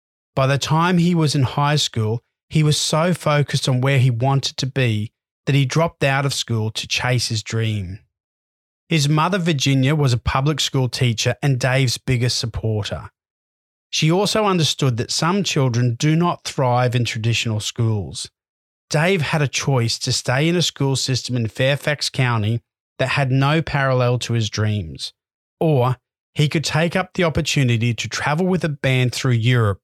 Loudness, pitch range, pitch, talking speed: -19 LUFS, 115-150 Hz, 130 Hz, 175 wpm